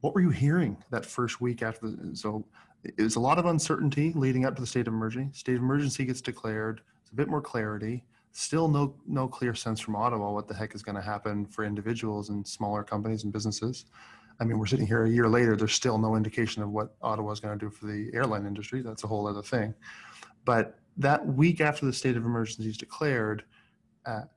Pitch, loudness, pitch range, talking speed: 110 Hz, -30 LUFS, 105-130 Hz, 230 wpm